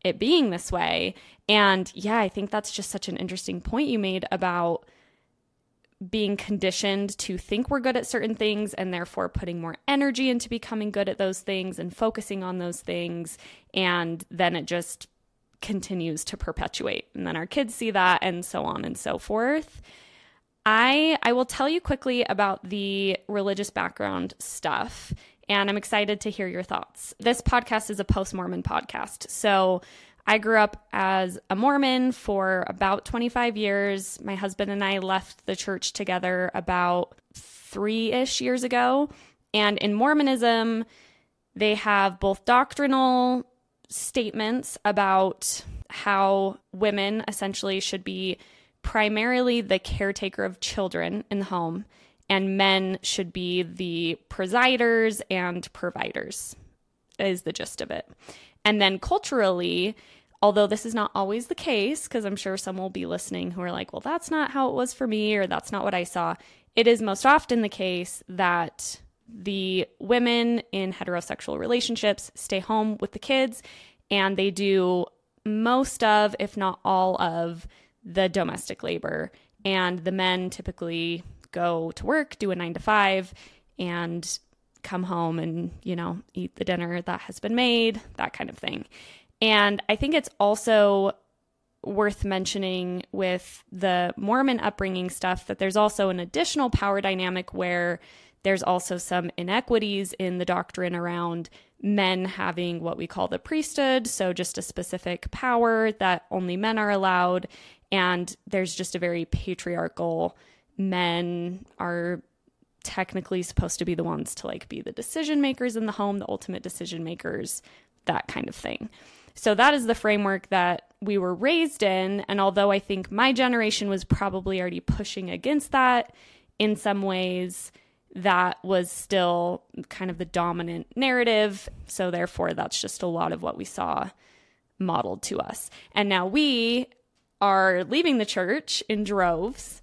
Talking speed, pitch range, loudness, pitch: 160 wpm, 180-225 Hz, -26 LUFS, 195 Hz